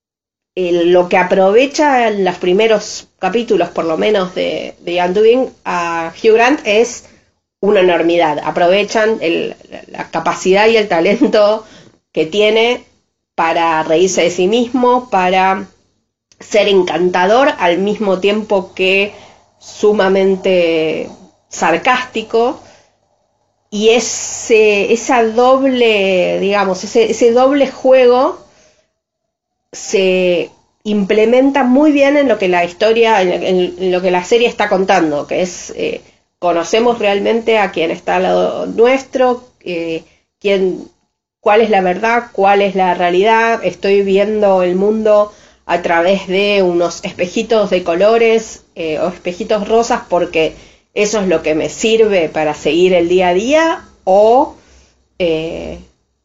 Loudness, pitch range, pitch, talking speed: -13 LUFS, 180-230 Hz, 200 Hz, 125 wpm